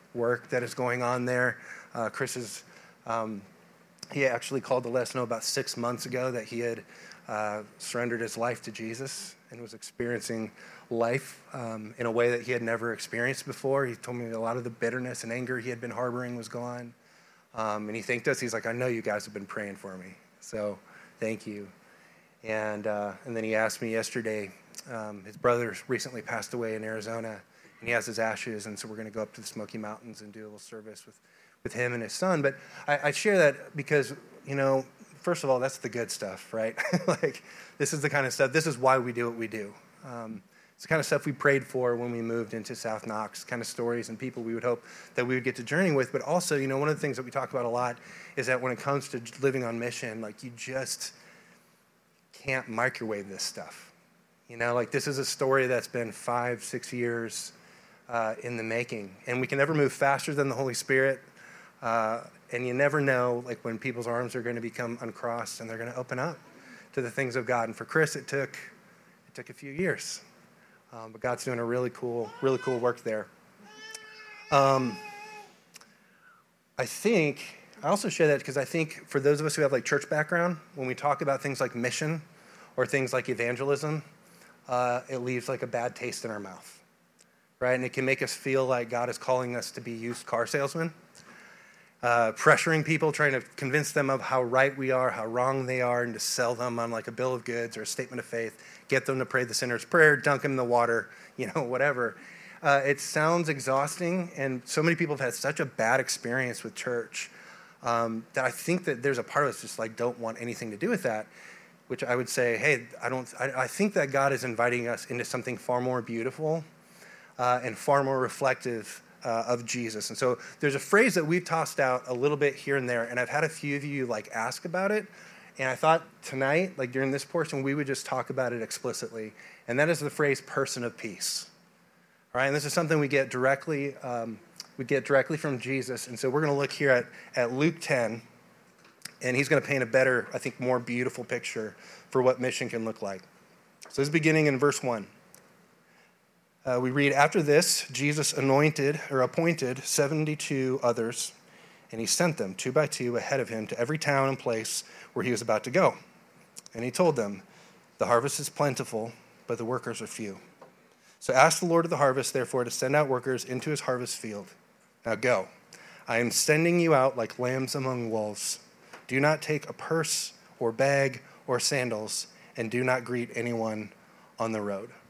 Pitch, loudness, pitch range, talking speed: 125 Hz, -29 LUFS, 115-140 Hz, 220 wpm